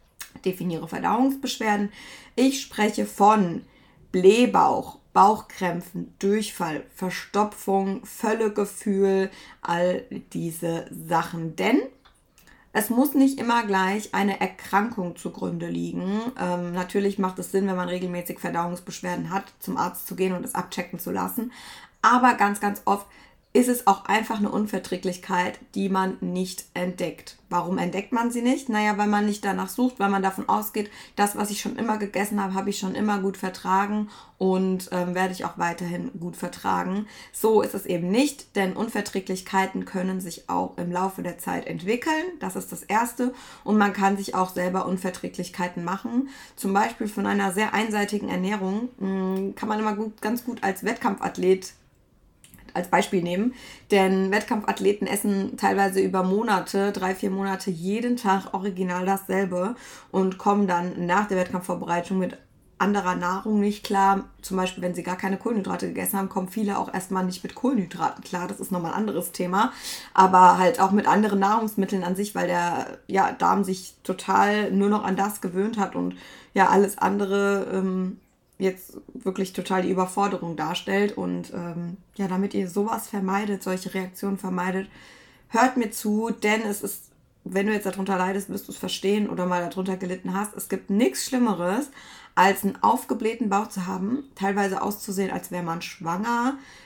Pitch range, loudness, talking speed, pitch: 185-210 Hz, -25 LUFS, 160 wpm, 195 Hz